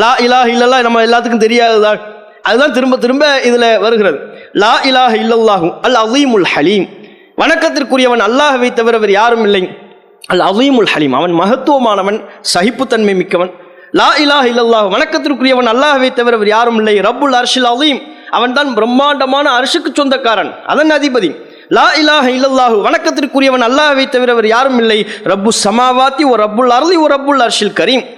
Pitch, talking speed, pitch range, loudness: 245 Hz, 145 wpm, 225-280 Hz, -9 LUFS